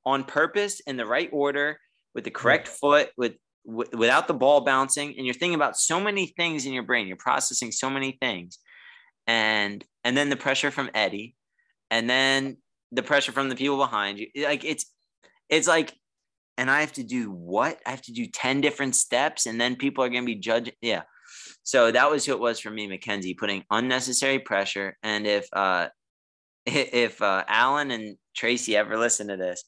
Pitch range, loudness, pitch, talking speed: 105-140 Hz, -24 LUFS, 125 Hz, 195 wpm